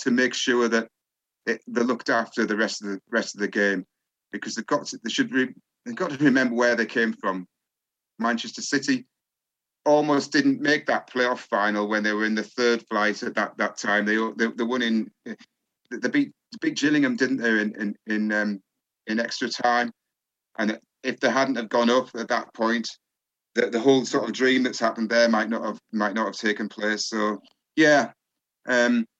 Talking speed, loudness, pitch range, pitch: 200 wpm, -24 LUFS, 105-125 Hz, 115 Hz